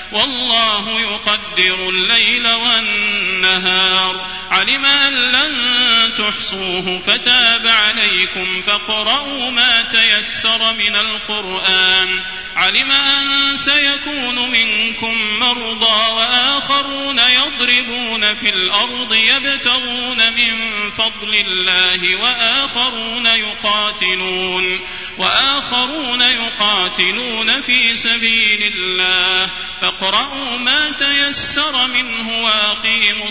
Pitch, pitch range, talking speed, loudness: 225 Hz, 205-245 Hz, 70 wpm, -13 LUFS